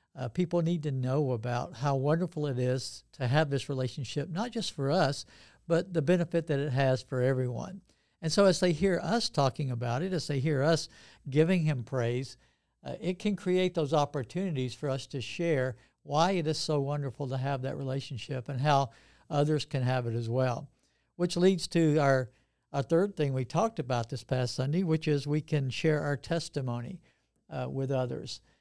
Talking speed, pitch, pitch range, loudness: 195 wpm, 145 Hz, 130-165 Hz, -30 LUFS